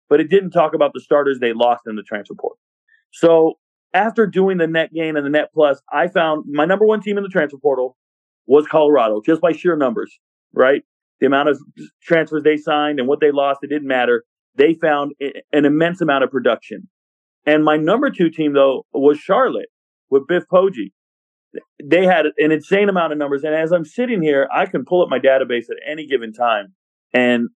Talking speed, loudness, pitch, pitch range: 205 wpm, -17 LUFS, 150 Hz, 135-170 Hz